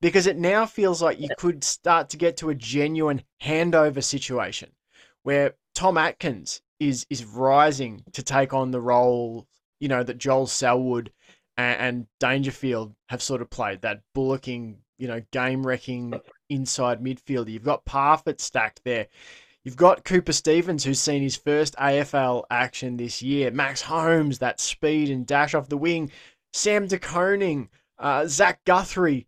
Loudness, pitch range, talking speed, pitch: -24 LUFS, 125-155 Hz, 155 wpm, 135 Hz